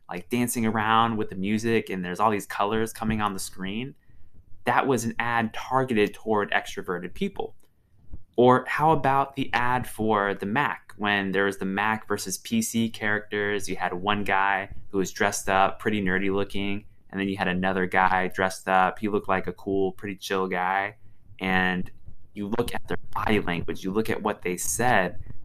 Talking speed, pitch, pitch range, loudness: 185 wpm, 100 Hz, 95-110 Hz, -26 LUFS